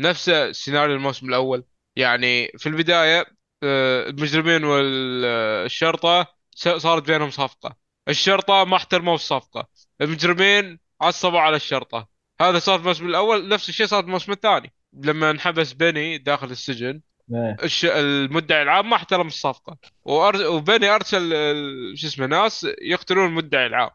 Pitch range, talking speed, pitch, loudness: 140-180 Hz, 125 wpm, 160 Hz, -20 LUFS